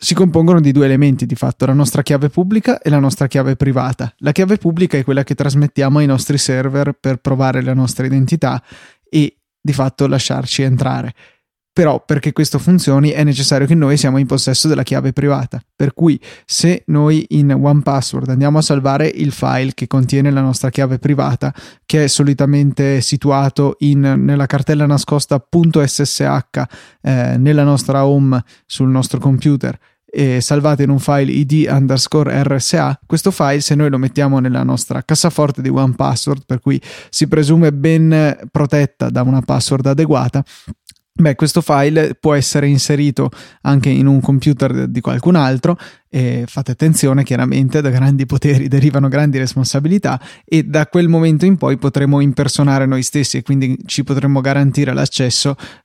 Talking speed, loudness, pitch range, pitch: 160 wpm, -14 LUFS, 135-150 Hz, 140 Hz